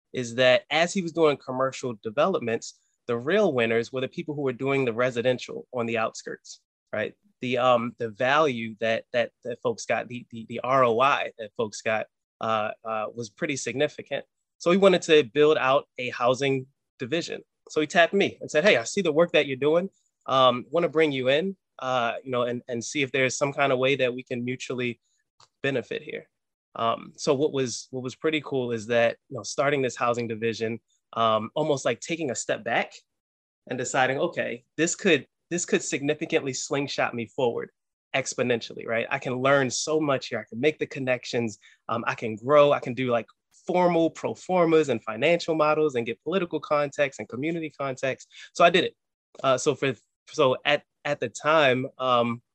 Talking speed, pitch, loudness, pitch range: 195 wpm, 130 Hz, -25 LUFS, 120-155 Hz